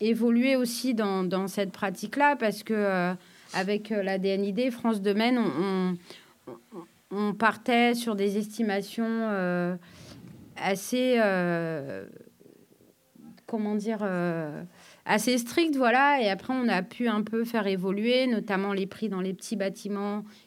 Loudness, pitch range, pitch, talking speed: -27 LUFS, 190-230 Hz, 210 Hz, 135 wpm